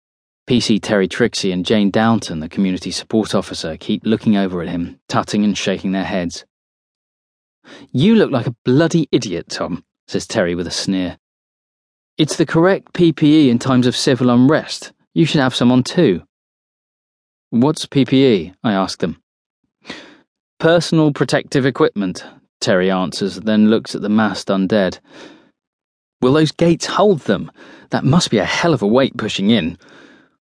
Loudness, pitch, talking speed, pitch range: -16 LUFS, 115 Hz, 155 wpm, 95-145 Hz